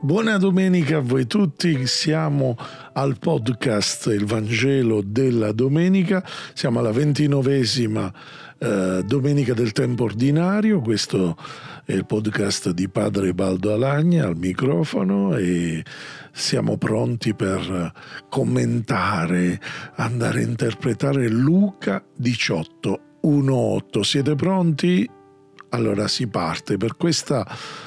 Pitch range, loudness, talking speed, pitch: 105-150 Hz, -21 LUFS, 100 wpm, 125 Hz